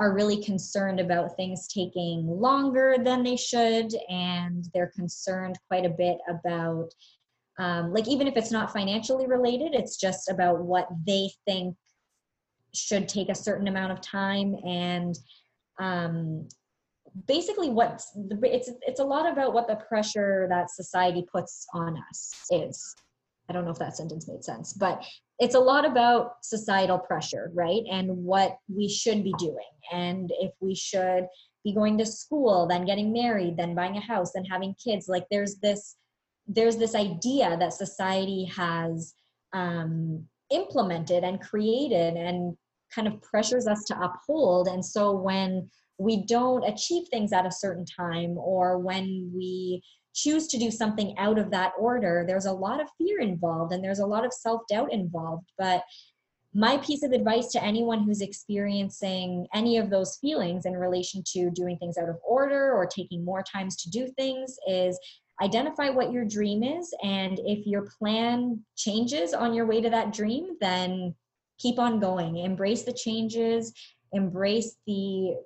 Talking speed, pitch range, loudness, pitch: 165 wpm, 180-230 Hz, -28 LUFS, 195 Hz